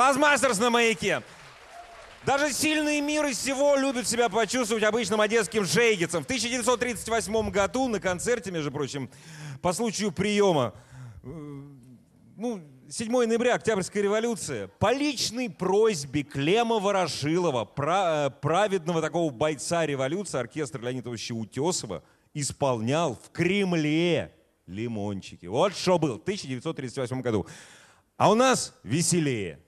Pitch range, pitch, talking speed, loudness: 140-230 Hz, 175 Hz, 110 wpm, -26 LUFS